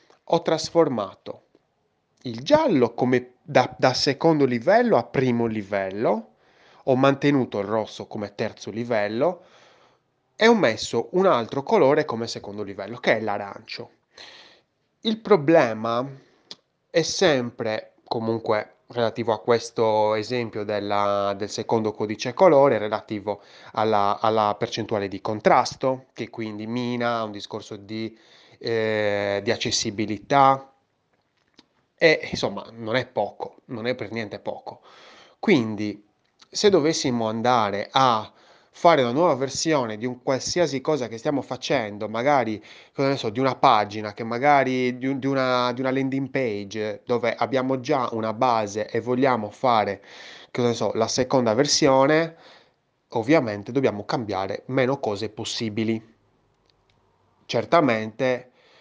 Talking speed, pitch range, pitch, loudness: 125 wpm, 110-135 Hz, 120 Hz, -23 LUFS